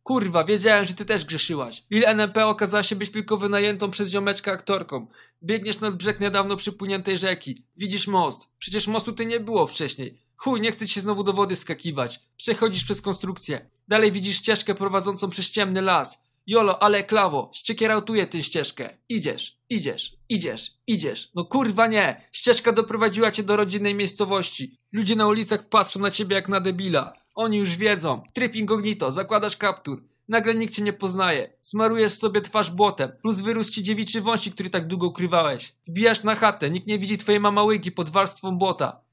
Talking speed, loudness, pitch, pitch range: 170 wpm, -23 LUFS, 205 Hz, 190-215 Hz